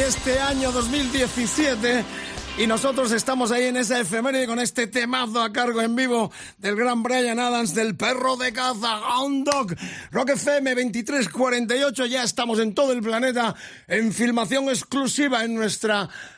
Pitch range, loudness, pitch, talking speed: 230-260 Hz, -22 LUFS, 245 Hz, 150 wpm